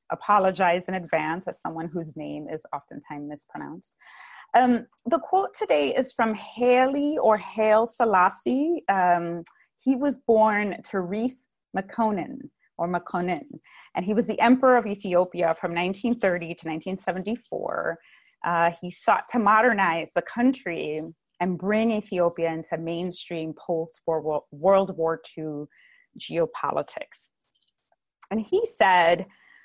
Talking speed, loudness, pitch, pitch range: 120 wpm, -25 LUFS, 190 Hz, 170-235 Hz